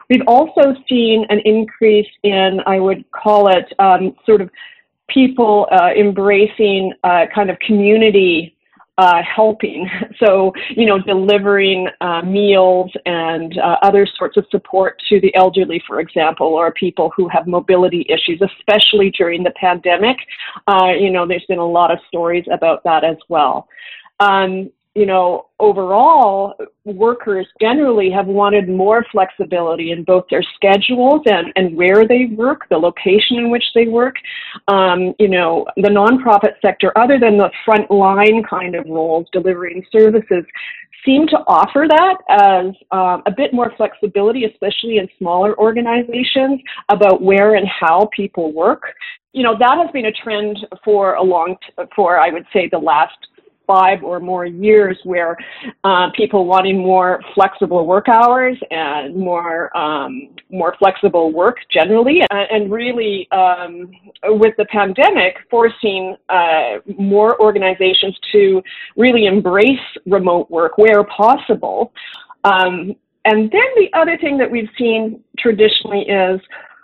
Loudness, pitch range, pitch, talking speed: -13 LUFS, 185-225 Hz, 200 Hz, 145 wpm